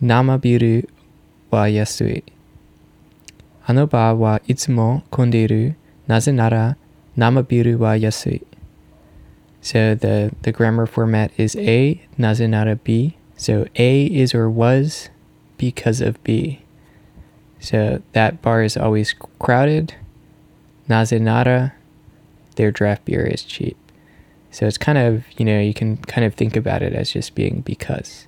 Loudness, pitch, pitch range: -18 LUFS, 115 Hz, 110-125 Hz